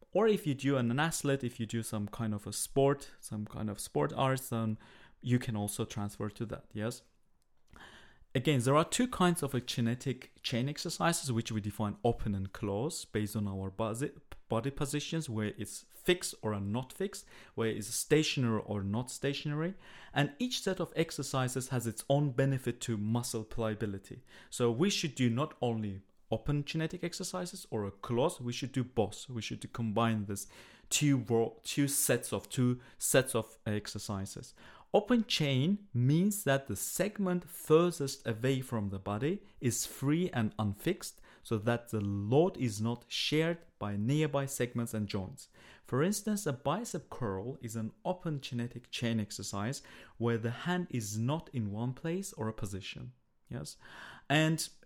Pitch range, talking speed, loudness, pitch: 110-150 Hz, 165 wpm, -34 LUFS, 125 Hz